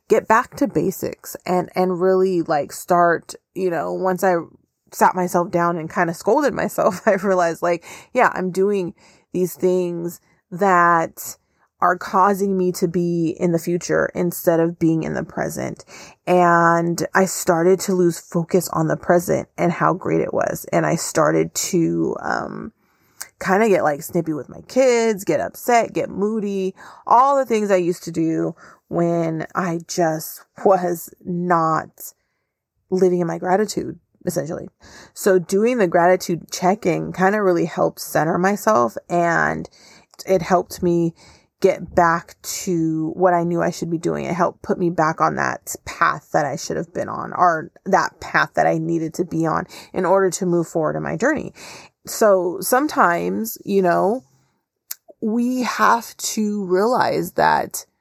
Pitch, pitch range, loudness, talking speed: 180 Hz, 170-190 Hz, -20 LUFS, 160 wpm